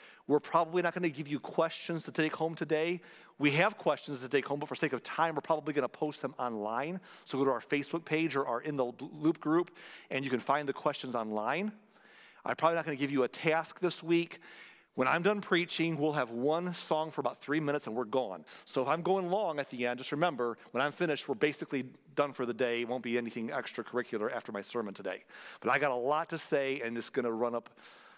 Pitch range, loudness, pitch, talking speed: 125-165 Hz, -33 LUFS, 150 Hz, 245 wpm